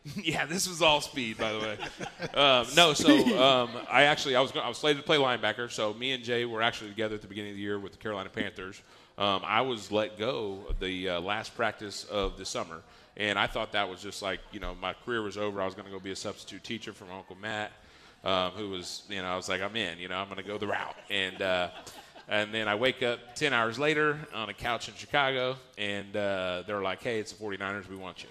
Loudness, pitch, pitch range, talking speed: -29 LUFS, 105 Hz, 95-120 Hz, 260 wpm